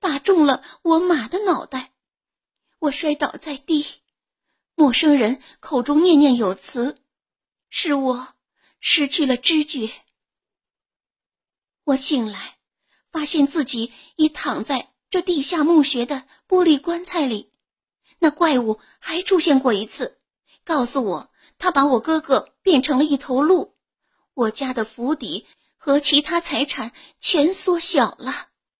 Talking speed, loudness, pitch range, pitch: 180 characters per minute, -19 LUFS, 260-325 Hz, 290 Hz